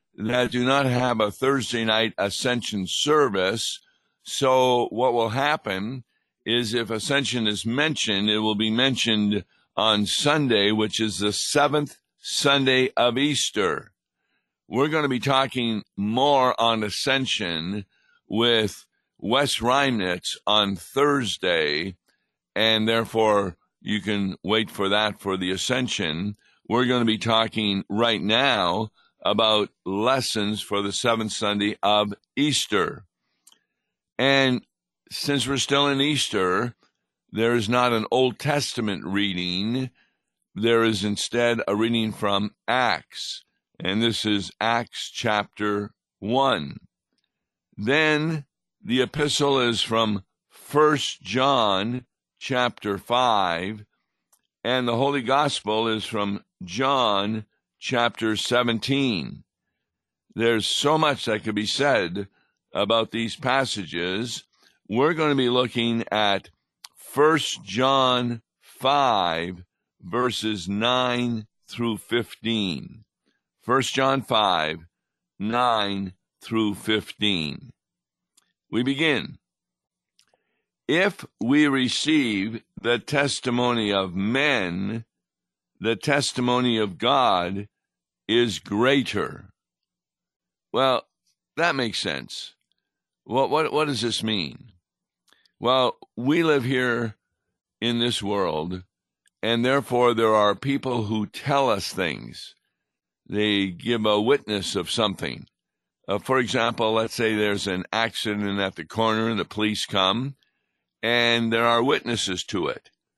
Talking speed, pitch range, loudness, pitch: 110 wpm, 105-125 Hz, -23 LUFS, 115 Hz